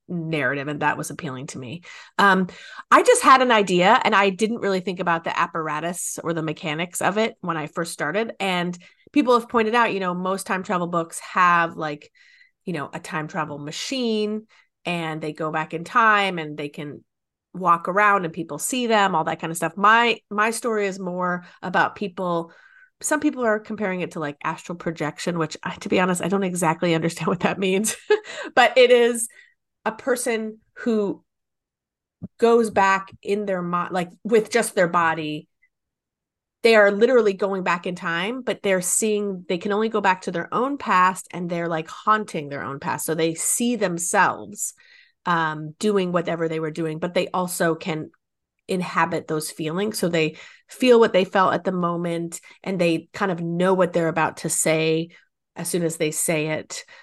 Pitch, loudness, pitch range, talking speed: 180 Hz, -22 LUFS, 165-215 Hz, 190 wpm